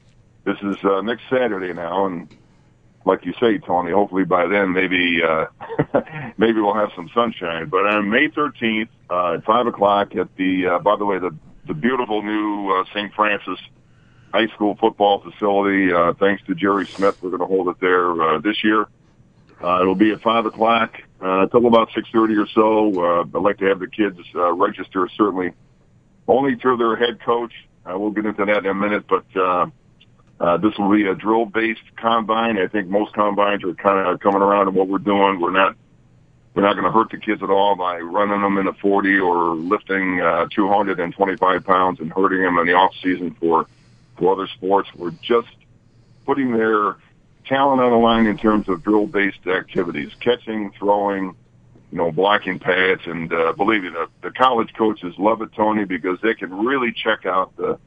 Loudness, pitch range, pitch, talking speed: -19 LUFS, 95-110 Hz, 100 Hz, 195 wpm